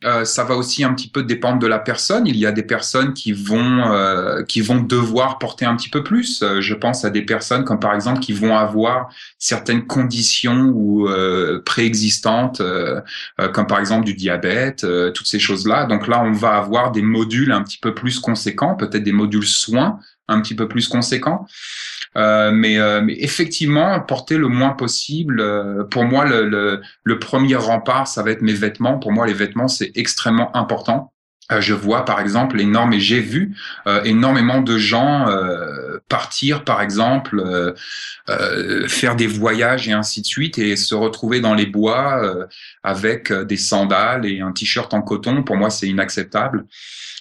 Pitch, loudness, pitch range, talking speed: 115 Hz, -17 LUFS, 105-125 Hz, 185 wpm